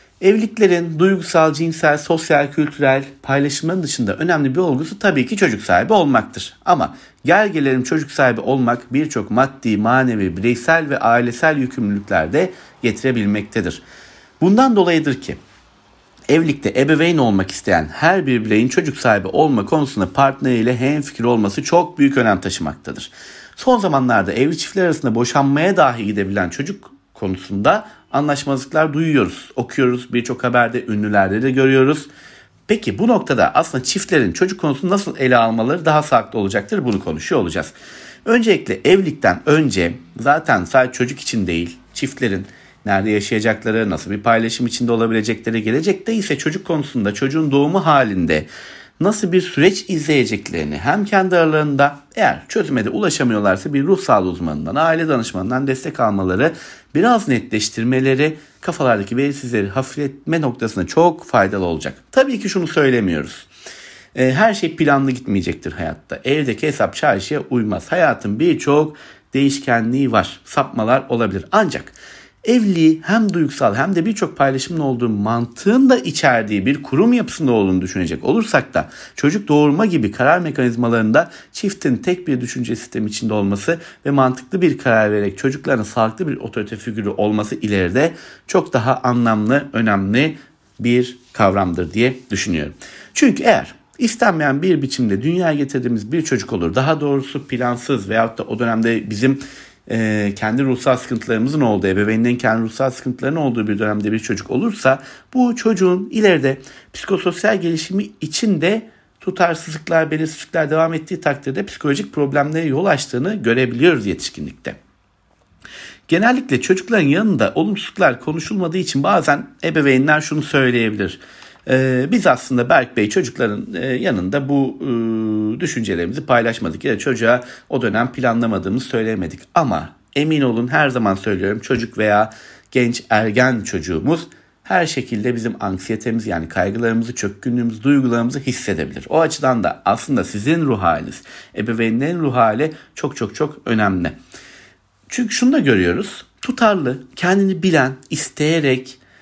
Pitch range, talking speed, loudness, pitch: 115-155 Hz, 130 wpm, -17 LUFS, 130 Hz